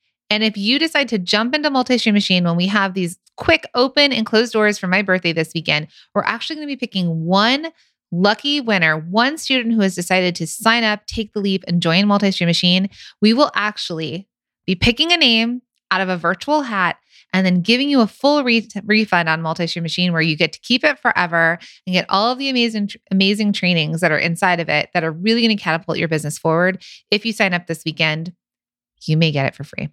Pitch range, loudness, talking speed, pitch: 170-230 Hz, -17 LUFS, 225 wpm, 195 Hz